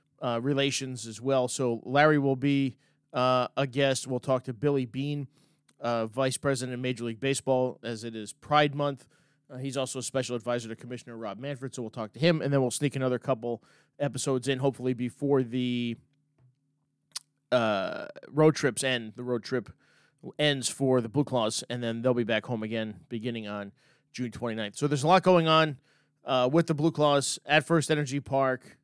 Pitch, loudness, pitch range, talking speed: 130 Hz, -28 LUFS, 125-145 Hz, 190 wpm